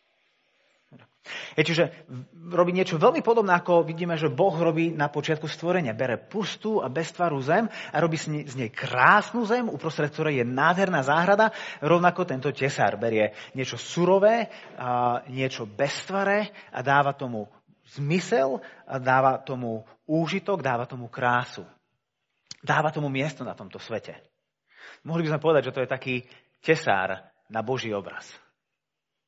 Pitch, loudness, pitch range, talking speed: 155 Hz, -25 LUFS, 130-175 Hz, 135 wpm